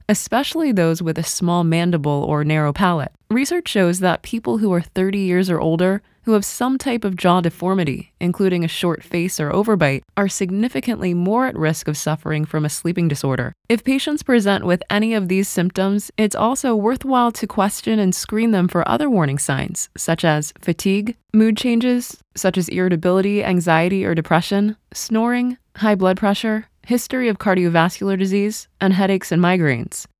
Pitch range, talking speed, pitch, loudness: 170-220 Hz, 170 wpm, 190 Hz, -19 LUFS